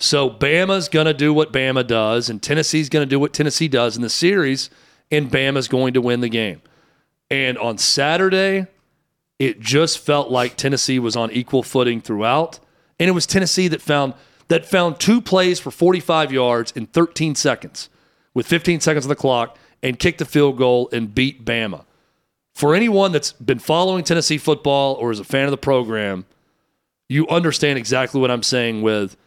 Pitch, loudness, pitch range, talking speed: 140 Hz, -18 LUFS, 125-160 Hz, 185 wpm